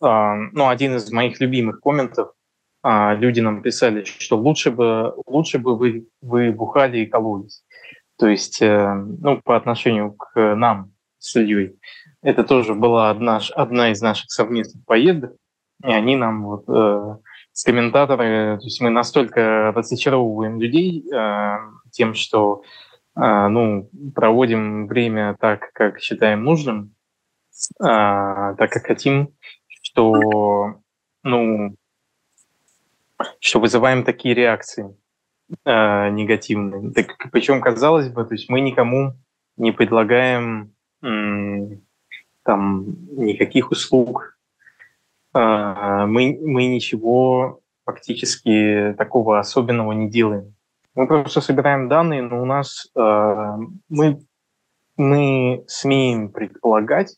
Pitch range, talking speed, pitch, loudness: 105-130 Hz, 115 wpm, 115 Hz, -18 LUFS